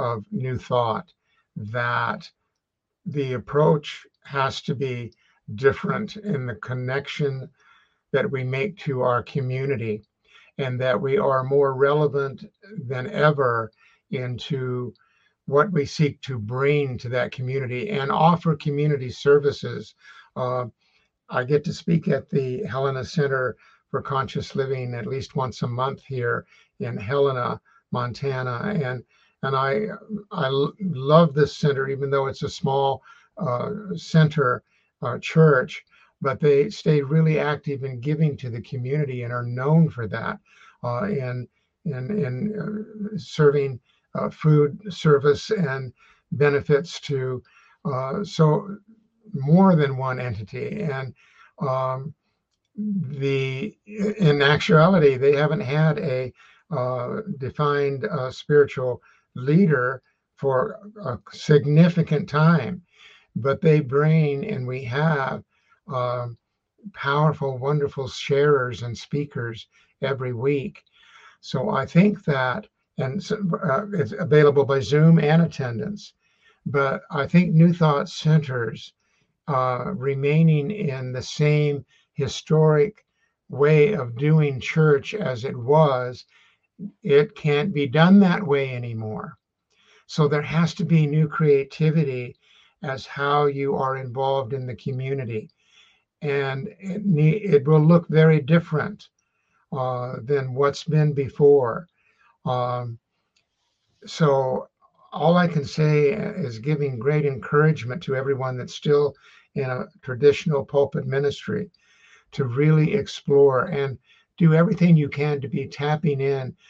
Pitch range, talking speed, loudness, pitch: 130-160 Hz, 125 wpm, -22 LUFS, 145 Hz